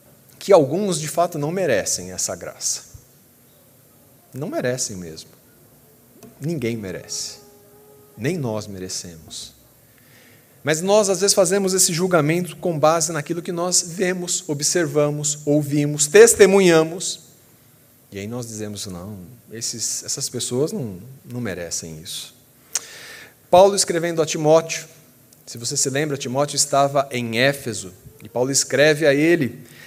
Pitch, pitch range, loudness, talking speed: 145 Hz, 120-170 Hz, -19 LUFS, 125 wpm